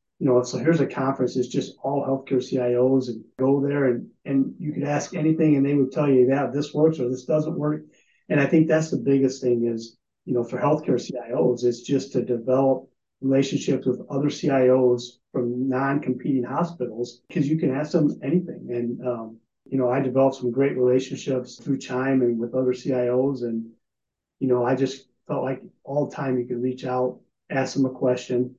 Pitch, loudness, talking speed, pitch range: 130 Hz, -24 LUFS, 205 wpm, 125-140 Hz